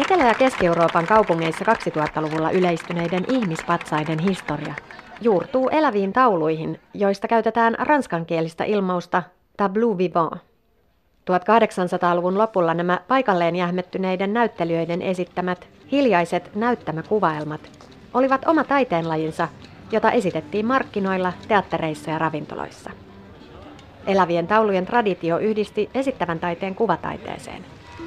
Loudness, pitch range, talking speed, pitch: -21 LUFS, 170-220 Hz, 90 wpm, 180 Hz